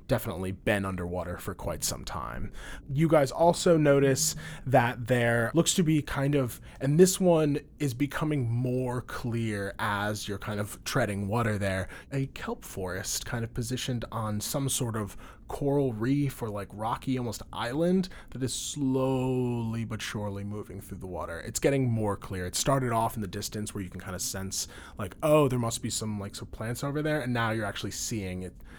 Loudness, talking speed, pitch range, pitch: -29 LUFS, 190 wpm, 100-135 Hz, 120 Hz